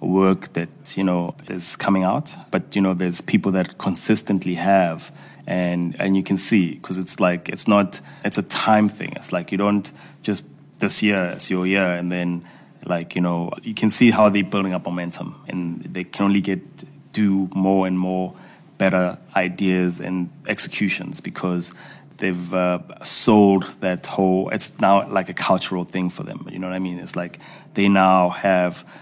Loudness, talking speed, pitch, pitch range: -20 LUFS, 185 wpm, 95 Hz, 90-100 Hz